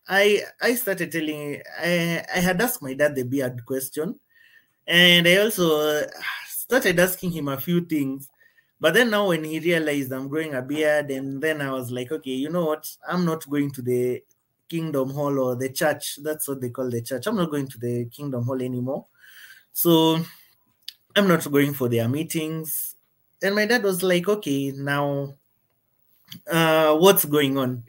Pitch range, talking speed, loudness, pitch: 135-175 Hz, 180 wpm, -23 LUFS, 150 Hz